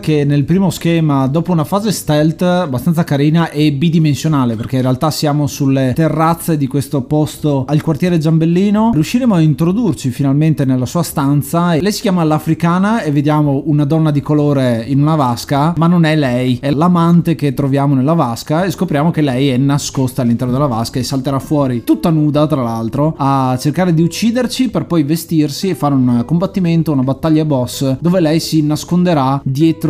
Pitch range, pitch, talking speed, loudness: 140-165 Hz, 150 Hz, 180 wpm, -14 LUFS